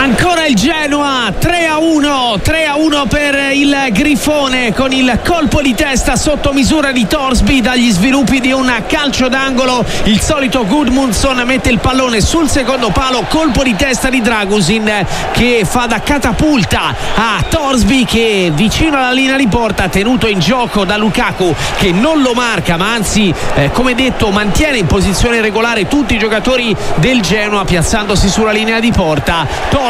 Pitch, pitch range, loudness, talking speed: 250 Hz, 215-275 Hz, -11 LUFS, 165 wpm